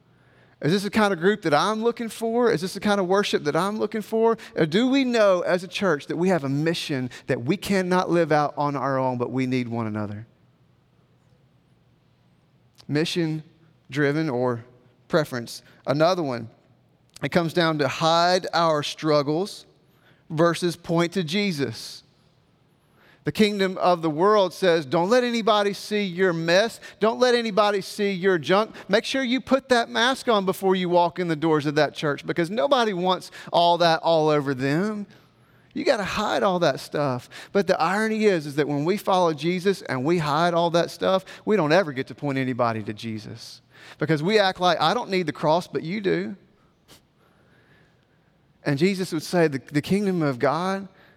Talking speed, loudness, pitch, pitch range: 185 wpm, -23 LUFS, 170 Hz, 150-200 Hz